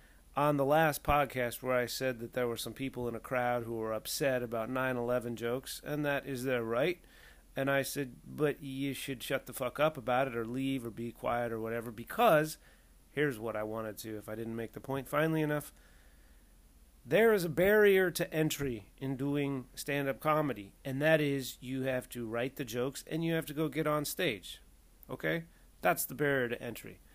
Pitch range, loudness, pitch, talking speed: 120-145 Hz, -33 LUFS, 130 Hz, 210 wpm